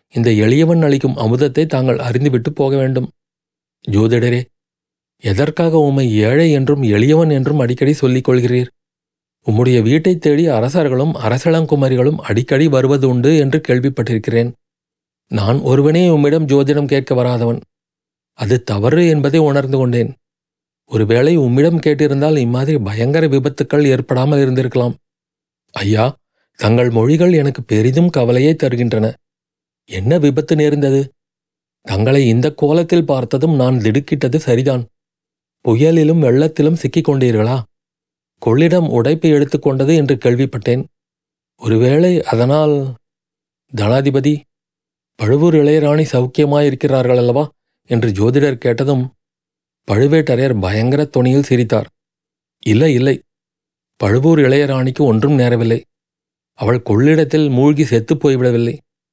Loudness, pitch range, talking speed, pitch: -14 LUFS, 120-150 Hz, 100 wpm, 135 Hz